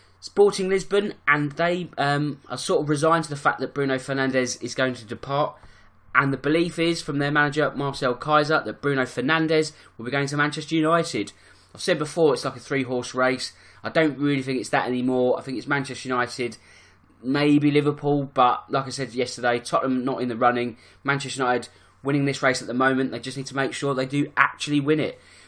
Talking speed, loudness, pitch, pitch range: 210 wpm, -23 LUFS, 135 Hz, 125-145 Hz